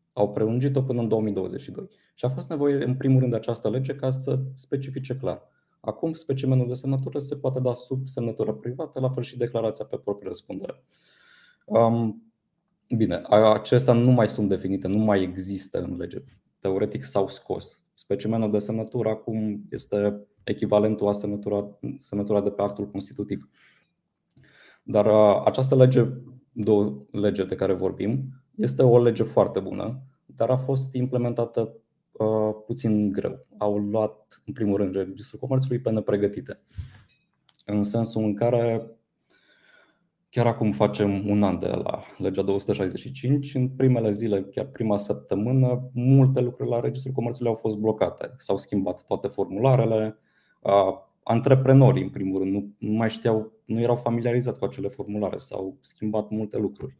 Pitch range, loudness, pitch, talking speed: 105-130 Hz, -25 LUFS, 115 Hz, 150 wpm